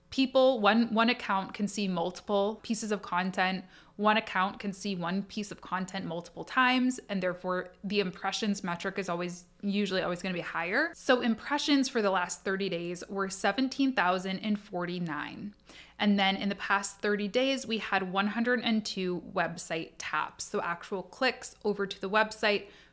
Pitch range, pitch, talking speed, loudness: 185-220 Hz, 200 Hz, 160 wpm, -30 LUFS